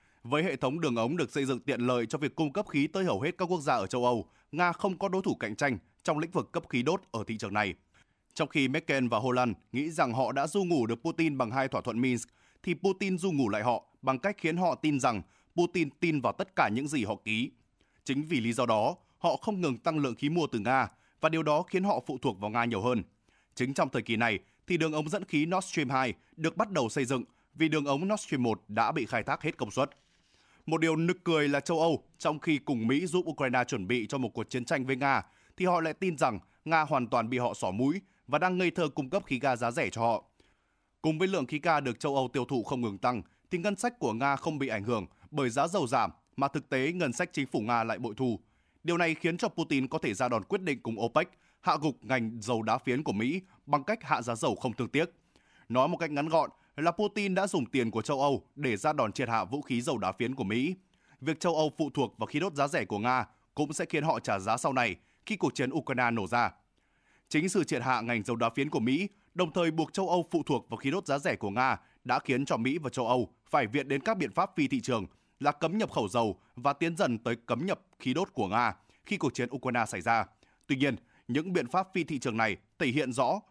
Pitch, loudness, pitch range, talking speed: 145 Hz, -31 LUFS, 125-170 Hz, 265 wpm